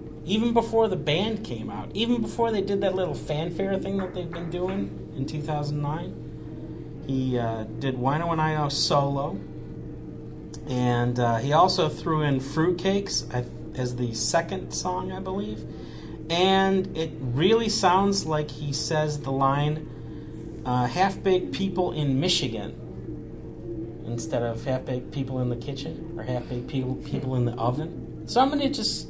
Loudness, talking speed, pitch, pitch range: -26 LUFS, 155 wpm, 150 Hz, 125-180 Hz